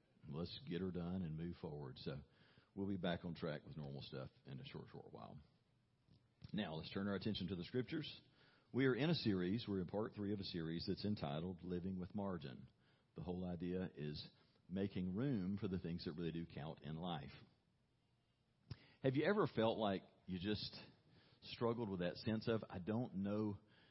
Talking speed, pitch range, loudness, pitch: 190 wpm, 90-115 Hz, -45 LUFS, 100 Hz